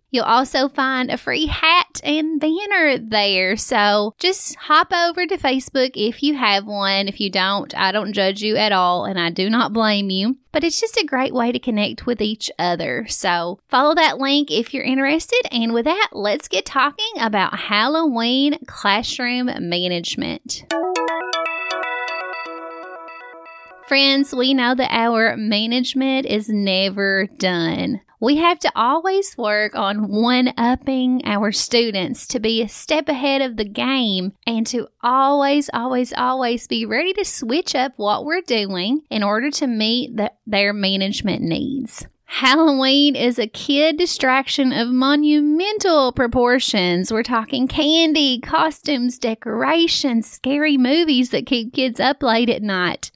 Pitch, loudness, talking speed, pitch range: 245 Hz, -18 LUFS, 150 wpm, 210-280 Hz